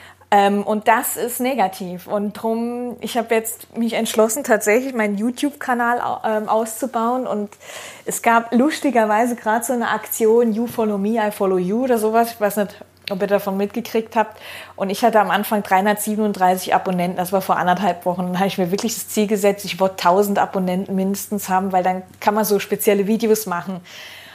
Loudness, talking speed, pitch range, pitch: -19 LUFS, 180 wpm, 195-230 Hz, 215 Hz